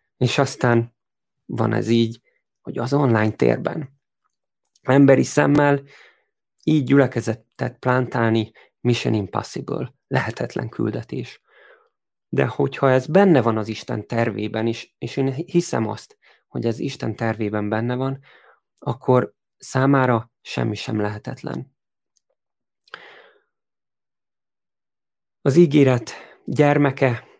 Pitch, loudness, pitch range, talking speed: 125 Hz, -21 LUFS, 115-145 Hz, 100 wpm